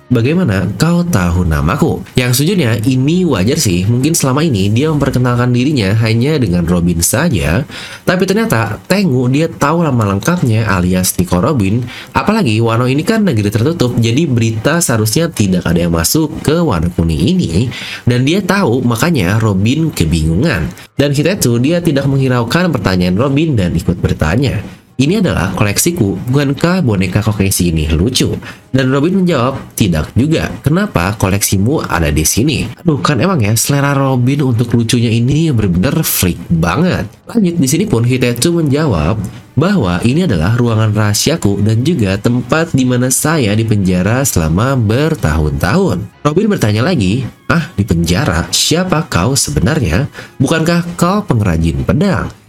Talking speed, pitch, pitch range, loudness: 145 wpm, 120 Hz, 95-150 Hz, -12 LUFS